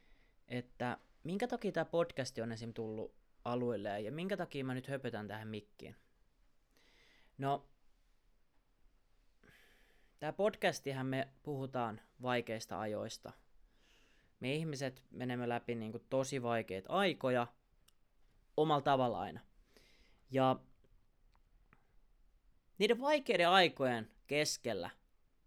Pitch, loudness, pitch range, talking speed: 130 Hz, -38 LUFS, 115-145 Hz, 95 wpm